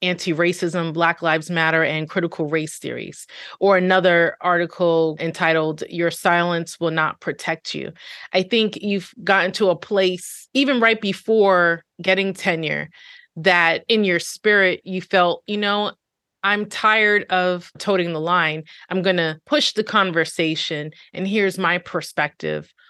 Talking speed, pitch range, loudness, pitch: 145 wpm, 165-195 Hz, -19 LUFS, 180 Hz